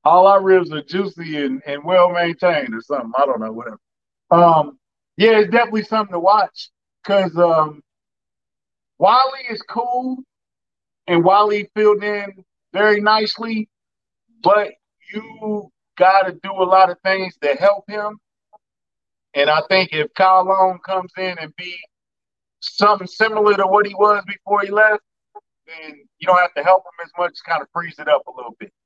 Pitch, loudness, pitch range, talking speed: 190 Hz, -17 LUFS, 170-210 Hz, 165 wpm